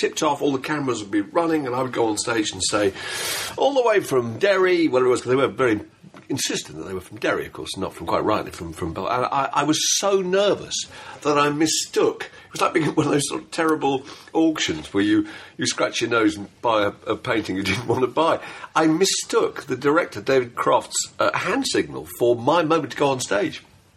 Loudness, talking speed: -22 LUFS, 240 wpm